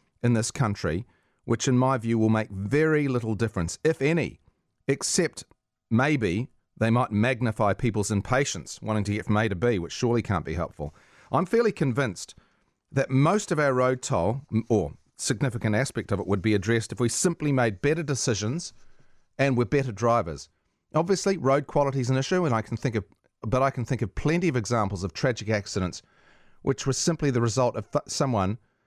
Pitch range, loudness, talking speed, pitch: 105-135 Hz, -26 LUFS, 185 wpm, 120 Hz